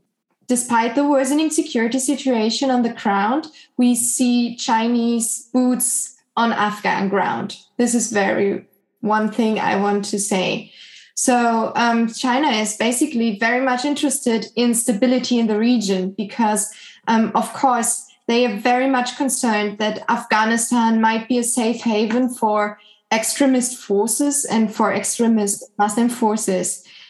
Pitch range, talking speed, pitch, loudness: 215-250 Hz, 135 wpm, 230 Hz, -19 LUFS